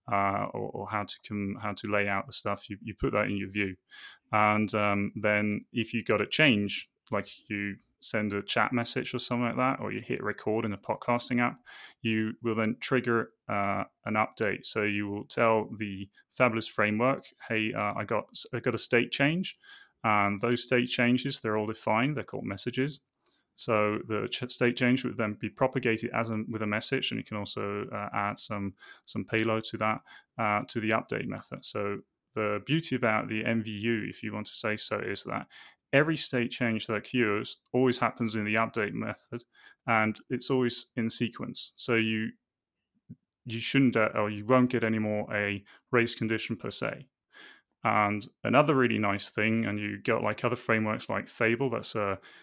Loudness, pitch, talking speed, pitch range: -30 LUFS, 110 Hz, 195 wpm, 105-120 Hz